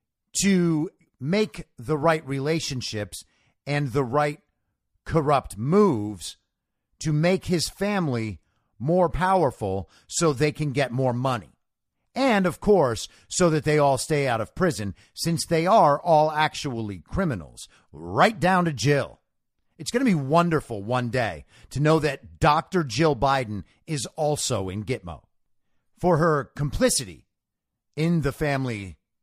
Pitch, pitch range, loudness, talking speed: 145 Hz, 115-165 Hz, -24 LUFS, 135 wpm